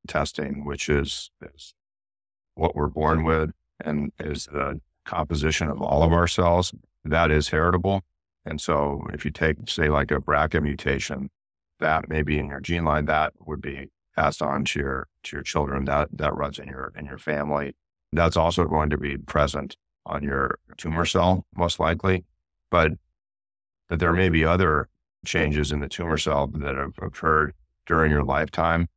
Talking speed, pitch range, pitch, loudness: 175 wpm, 70-85 Hz, 75 Hz, -24 LUFS